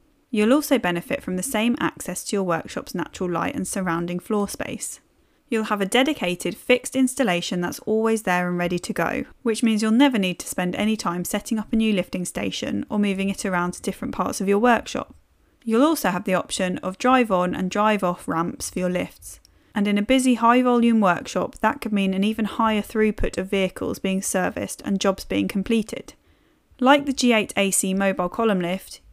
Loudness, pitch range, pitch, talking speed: -22 LUFS, 180-230 Hz, 205 Hz, 200 wpm